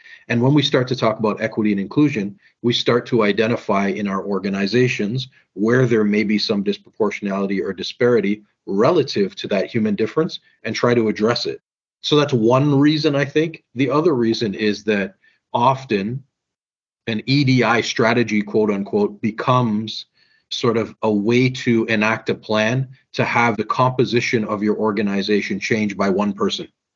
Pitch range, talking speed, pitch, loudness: 105-135 Hz, 160 wpm, 120 Hz, -19 LUFS